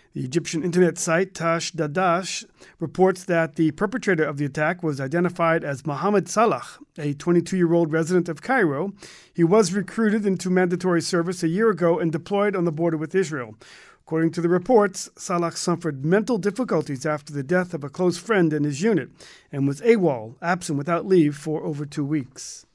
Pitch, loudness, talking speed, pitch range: 170 Hz, -23 LUFS, 180 wpm, 155-185 Hz